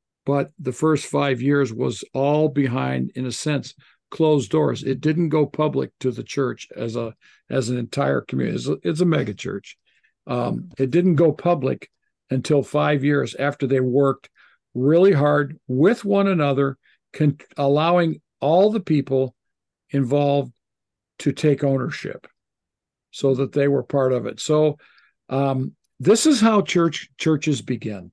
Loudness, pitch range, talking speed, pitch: -21 LUFS, 135-155 Hz, 155 wpm, 140 Hz